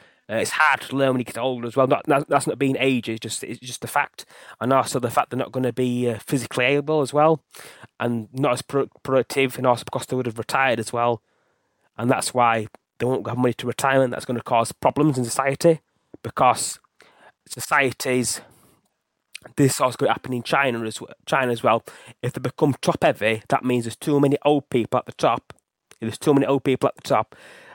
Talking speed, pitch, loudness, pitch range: 225 wpm, 130 Hz, -22 LUFS, 120-135 Hz